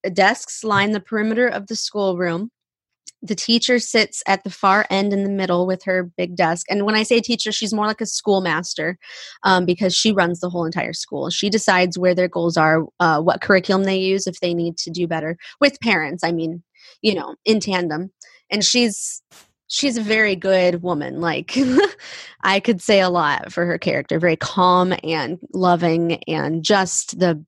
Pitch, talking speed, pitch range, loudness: 190 Hz, 190 wpm, 175-215 Hz, -19 LUFS